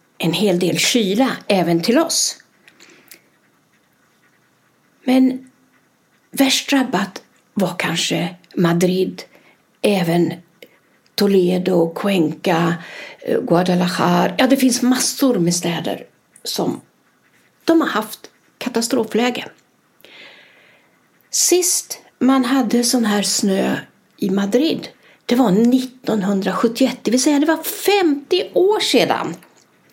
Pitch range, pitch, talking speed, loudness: 185-265 Hz, 235 Hz, 95 wpm, -17 LUFS